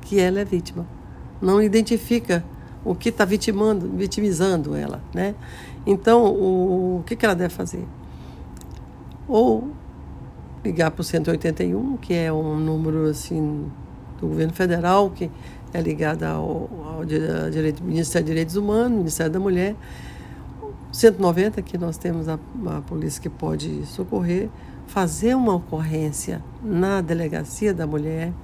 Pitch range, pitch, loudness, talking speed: 160-200 Hz, 180 Hz, -22 LUFS, 135 wpm